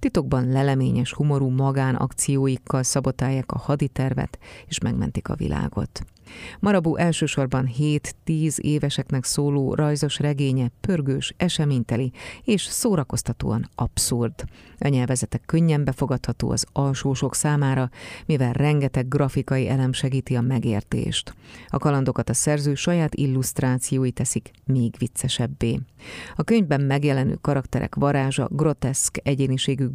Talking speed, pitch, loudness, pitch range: 105 wpm, 135 Hz, -23 LUFS, 130-145 Hz